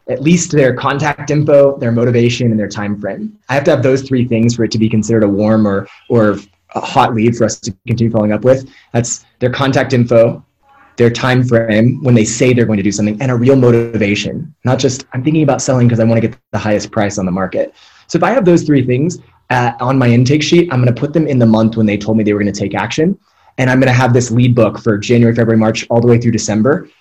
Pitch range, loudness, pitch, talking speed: 110-135 Hz, -12 LUFS, 120 Hz, 265 wpm